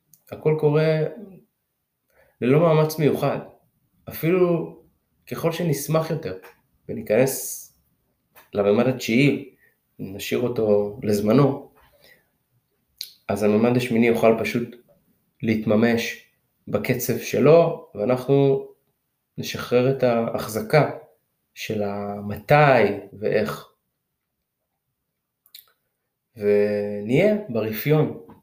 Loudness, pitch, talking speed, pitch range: -21 LUFS, 125 Hz, 70 wpm, 110-155 Hz